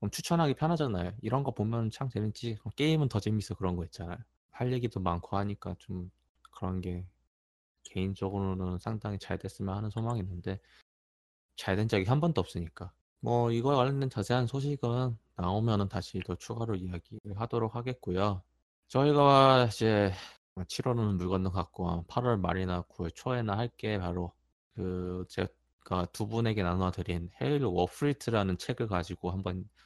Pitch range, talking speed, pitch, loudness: 90-120 Hz, 325 characters per minute, 100 Hz, -32 LUFS